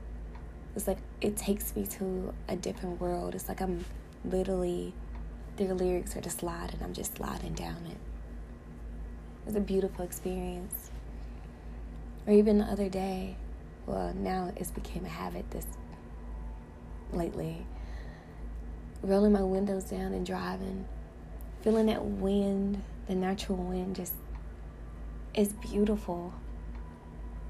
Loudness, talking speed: -33 LUFS, 120 wpm